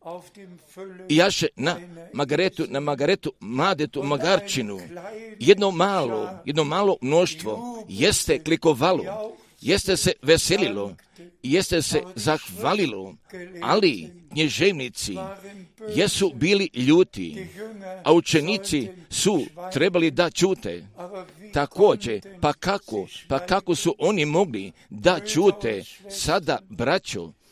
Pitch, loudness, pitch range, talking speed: 175 Hz, -23 LUFS, 155-195 Hz, 95 wpm